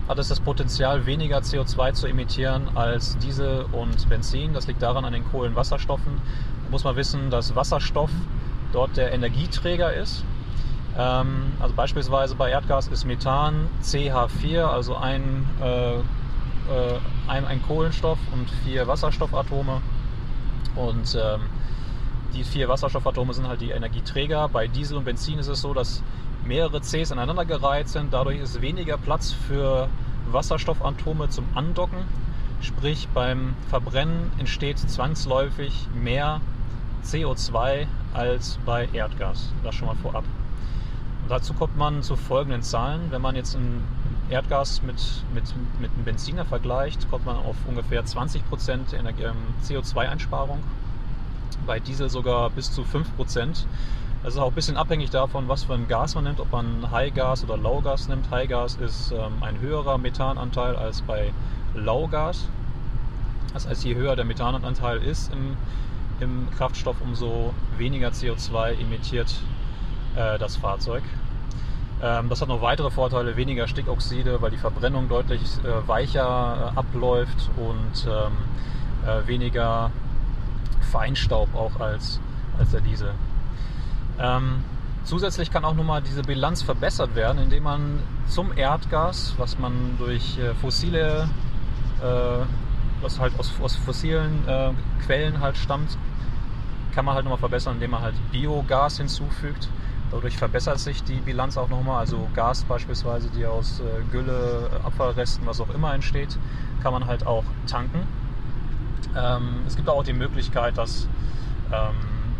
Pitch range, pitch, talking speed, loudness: 120-135 Hz, 125 Hz, 140 wpm, -26 LUFS